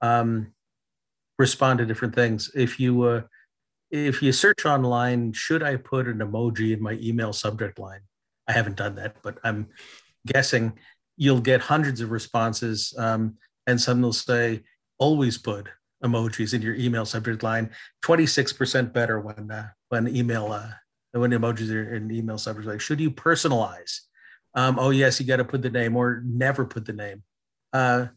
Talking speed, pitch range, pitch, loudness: 170 wpm, 110-130 Hz, 120 Hz, -24 LUFS